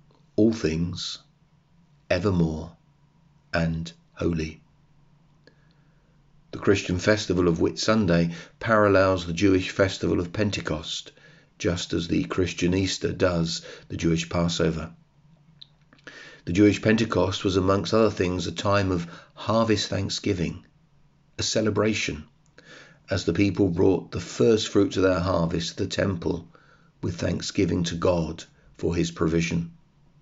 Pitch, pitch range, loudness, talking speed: 100 Hz, 85-145 Hz, -25 LUFS, 115 wpm